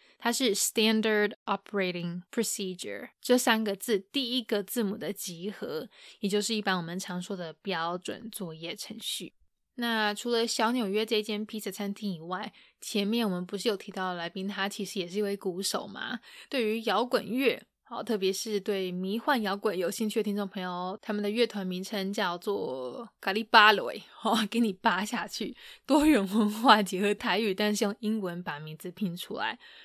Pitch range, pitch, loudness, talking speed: 190-225 Hz, 210 Hz, -29 LUFS, 305 characters per minute